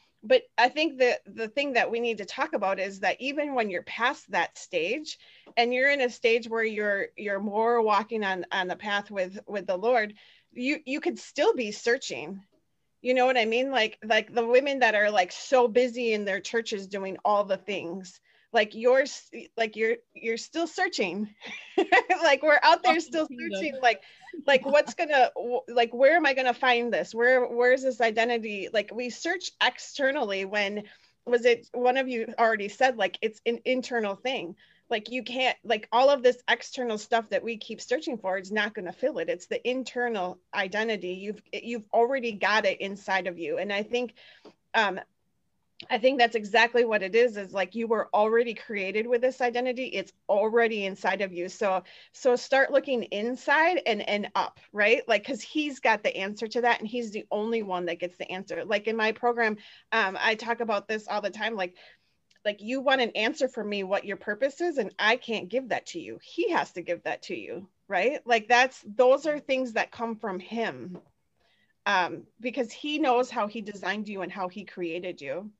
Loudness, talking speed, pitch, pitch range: -27 LUFS, 200 wpm, 230 Hz, 205-255 Hz